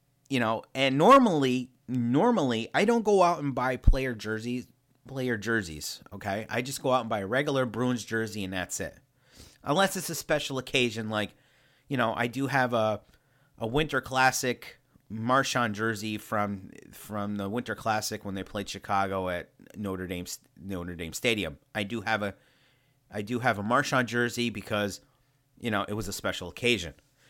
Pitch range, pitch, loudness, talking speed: 105-130 Hz, 120 Hz, -28 LUFS, 175 wpm